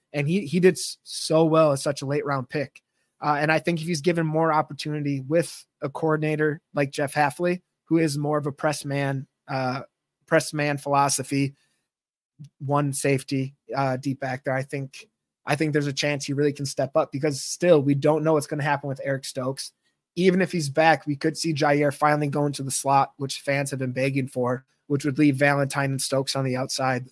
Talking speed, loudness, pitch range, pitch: 210 wpm, -24 LUFS, 135-155 Hz, 145 Hz